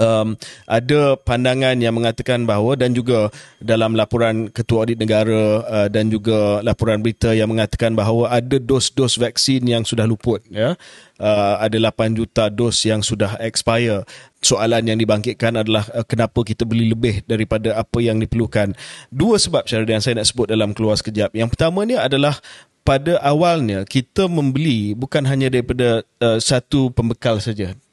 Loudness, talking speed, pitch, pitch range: -18 LUFS, 160 wpm, 115 Hz, 110-125 Hz